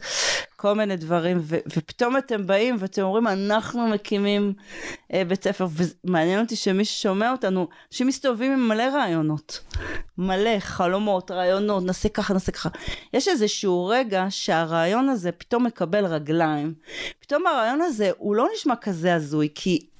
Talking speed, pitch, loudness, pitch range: 145 wpm, 195 Hz, -24 LUFS, 180-225 Hz